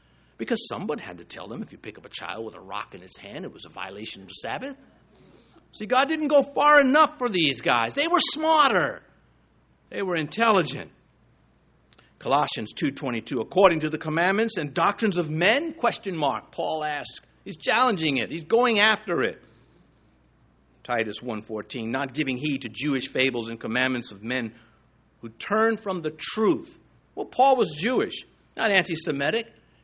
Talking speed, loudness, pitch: 175 wpm, -24 LUFS, 165 Hz